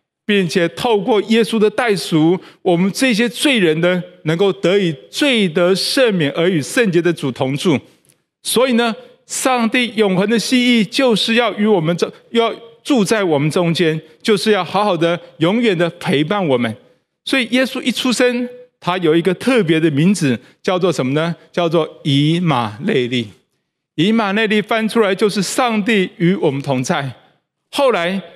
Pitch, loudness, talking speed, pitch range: 190 Hz, -16 LUFS, 240 characters per minute, 165-230 Hz